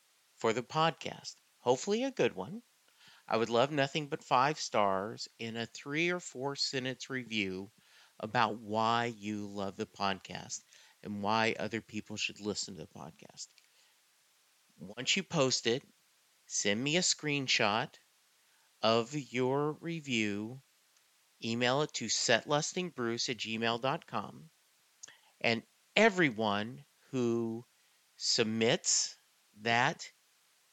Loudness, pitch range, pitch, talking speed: -33 LUFS, 110-145 Hz, 120 Hz, 115 wpm